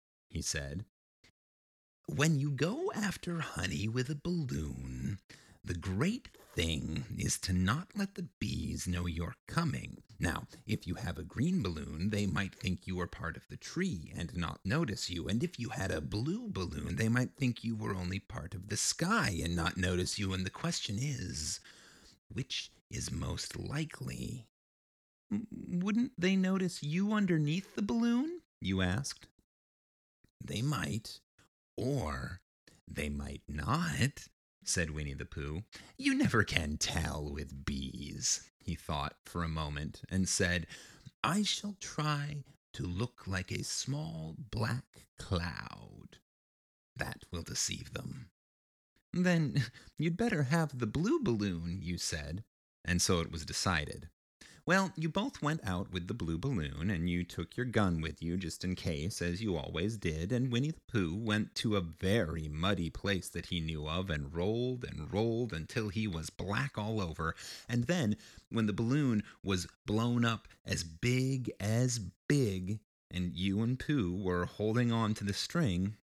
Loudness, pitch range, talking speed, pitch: -35 LUFS, 85-130 Hz, 160 wpm, 100 Hz